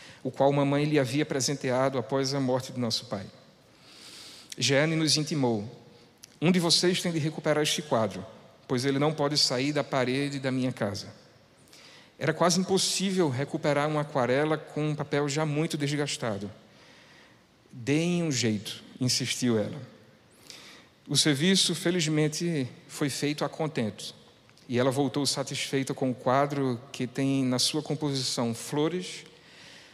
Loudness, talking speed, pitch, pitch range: -27 LUFS, 140 wpm, 140 Hz, 125-155 Hz